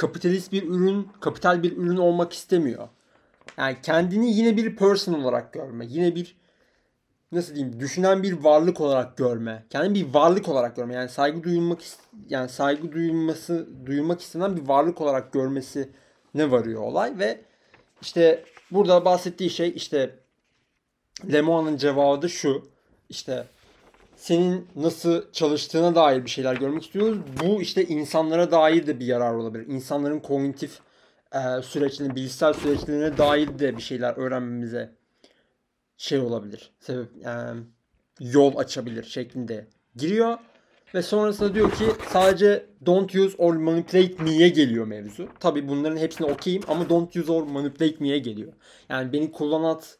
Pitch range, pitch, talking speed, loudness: 135-175 Hz, 155 Hz, 135 wpm, -23 LUFS